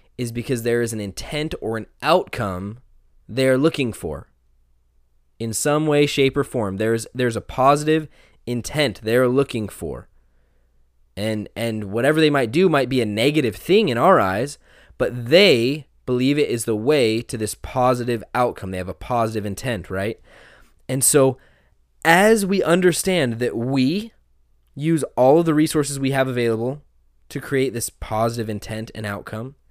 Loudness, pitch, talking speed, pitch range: -20 LUFS, 120 Hz, 160 wpm, 105-140 Hz